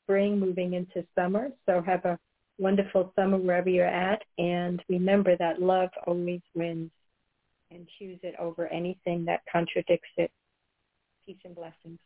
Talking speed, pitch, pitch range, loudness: 145 wpm, 175 Hz, 170-185 Hz, -28 LUFS